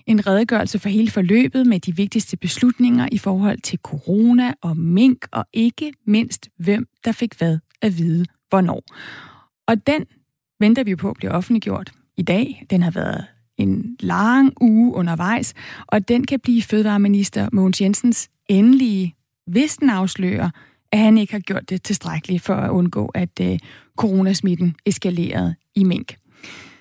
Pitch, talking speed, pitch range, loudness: 200 Hz, 150 wpm, 180-230 Hz, -19 LUFS